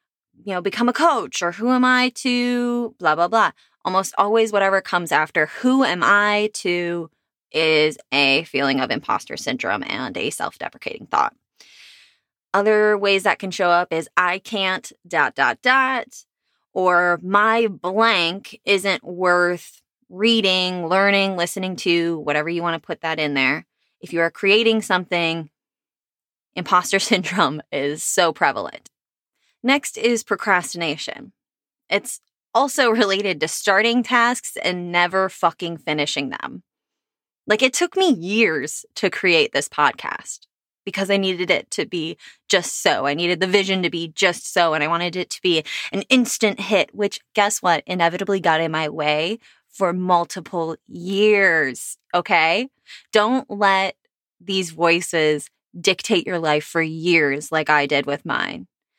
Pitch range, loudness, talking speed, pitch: 170-210 Hz, -19 LUFS, 150 wpm, 185 Hz